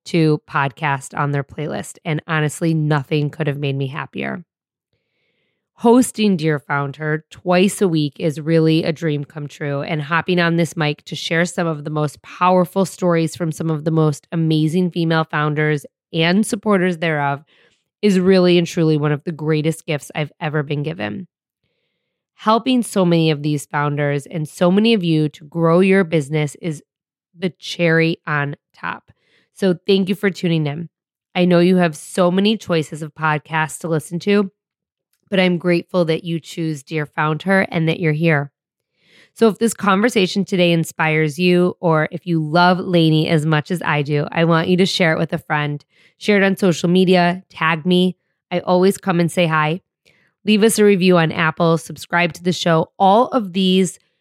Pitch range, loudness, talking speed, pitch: 155-180 Hz, -18 LUFS, 185 wpm, 165 Hz